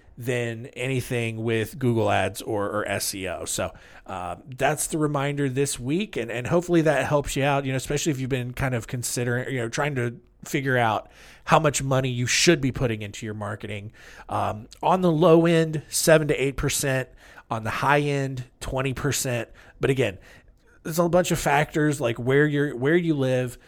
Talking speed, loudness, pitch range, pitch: 190 wpm, -24 LUFS, 120-145 Hz, 130 Hz